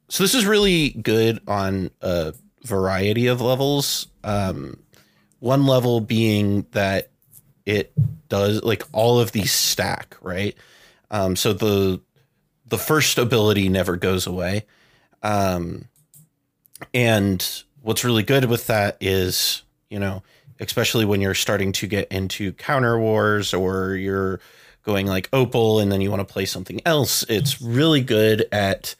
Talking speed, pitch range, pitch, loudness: 140 wpm, 95-120 Hz, 105 Hz, -21 LUFS